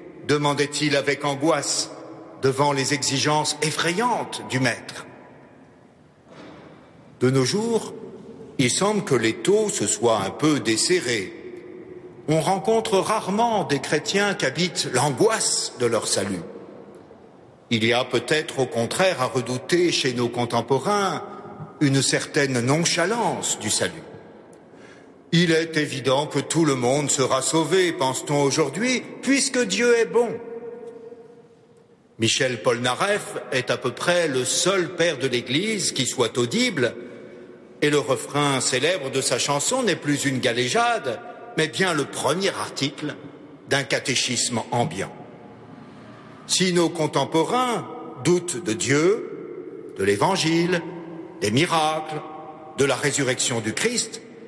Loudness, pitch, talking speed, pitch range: -22 LUFS, 155 Hz, 125 wpm, 135-205 Hz